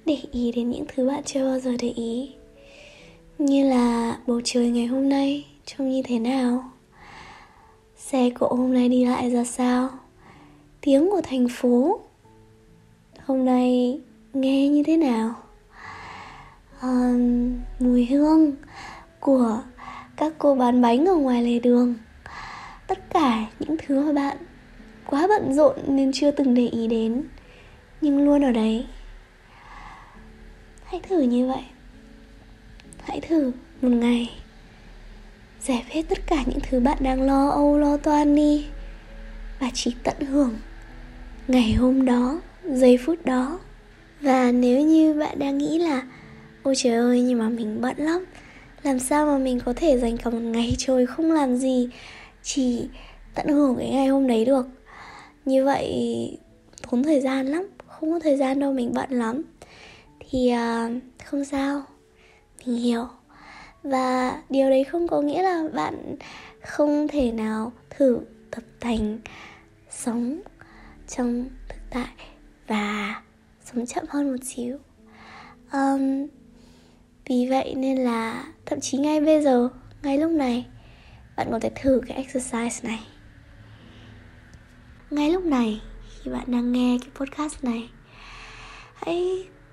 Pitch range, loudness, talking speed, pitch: 245-285 Hz, -23 LUFS, 145 wpm, 260 Hz